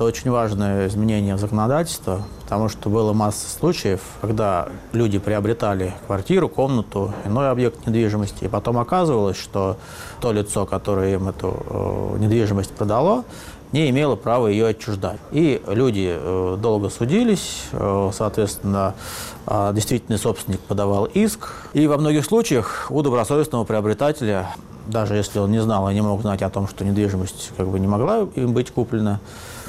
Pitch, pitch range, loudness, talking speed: 105 Hz, 100-120 Hz, -21 LUFS, 145 wpm